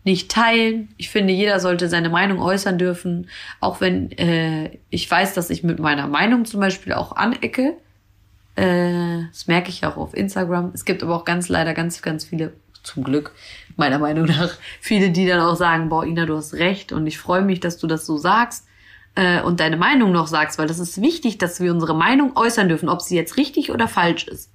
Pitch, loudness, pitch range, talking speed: 175 Hz, -19 LUFS, 160-190 Hz, 215 wpm